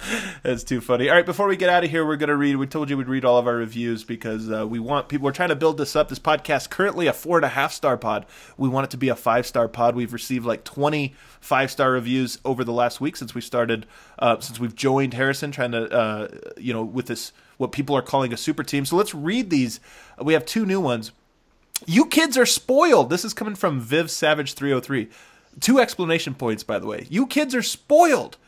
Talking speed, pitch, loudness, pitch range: 250 wpm, 140 Hz, -22 LUFS, 120-165 Hz